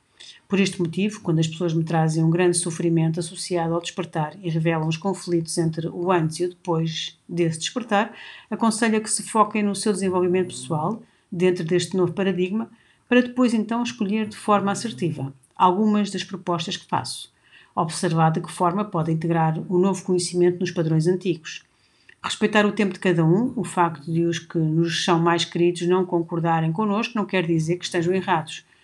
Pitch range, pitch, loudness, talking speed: 170-200 Hz, 180 Hz, -23 LUFS, 180 wpm